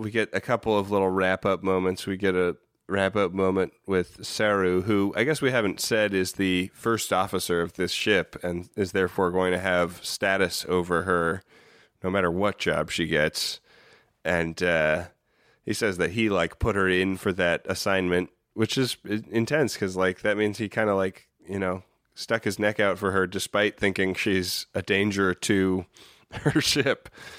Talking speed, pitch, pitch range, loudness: 180 wpm, 95 Hz, 90-105 Hz, -25 LUFS